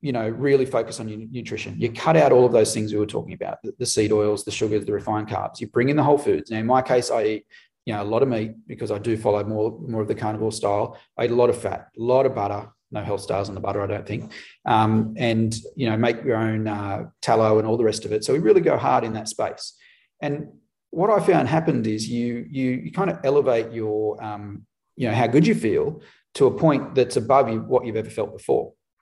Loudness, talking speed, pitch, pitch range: -22 LUFS, 265 wpm, 110 Hz, 110-125 Hz